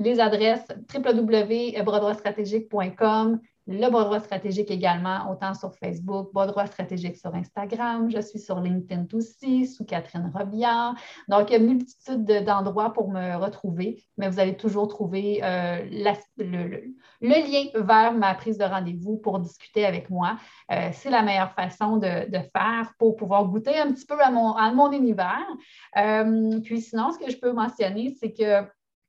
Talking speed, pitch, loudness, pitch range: 165 wpm, 210 Hz, -25 LUFS, 195-230 Hz